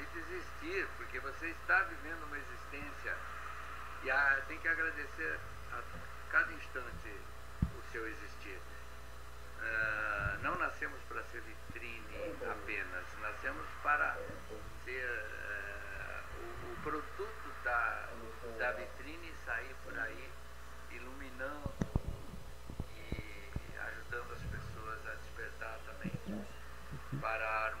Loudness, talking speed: -40 LUFS, 100 wpm